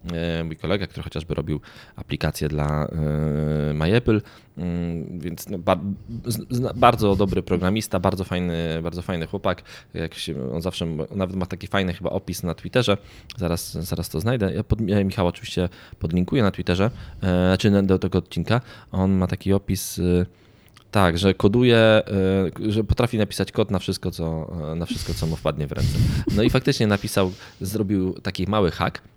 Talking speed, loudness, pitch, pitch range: 150 wpm, -23 LUFS, 95 Hz, 85-105 Hz